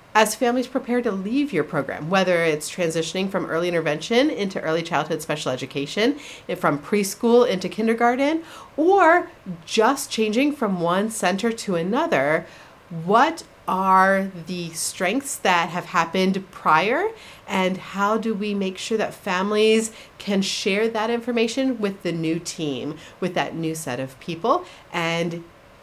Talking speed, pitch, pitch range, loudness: 140 wpm, 190 Hz, 170-225 Hz, -22 LUFS